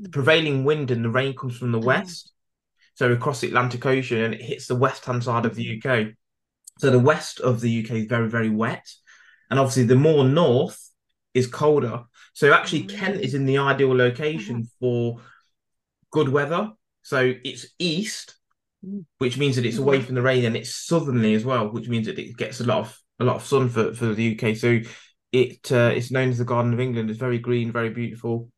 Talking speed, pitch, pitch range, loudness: 210 wpm, 125 Hz, 115-140 Hz, -22 LUFS